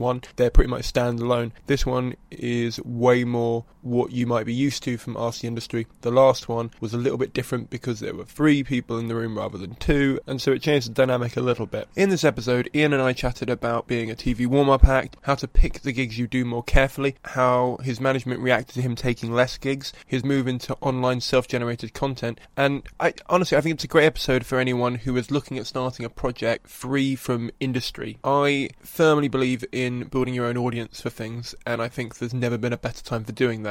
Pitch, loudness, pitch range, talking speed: 125 Hz, -24 LUFS, 120-135 Hz, 230 wpm